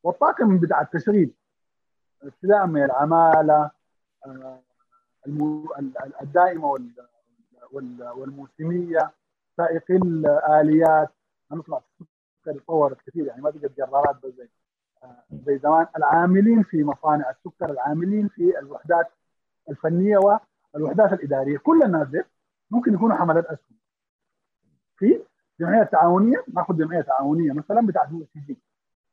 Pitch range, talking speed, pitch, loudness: 140-185 Hz, 105 wpm, 160 Hz, -21 LUFS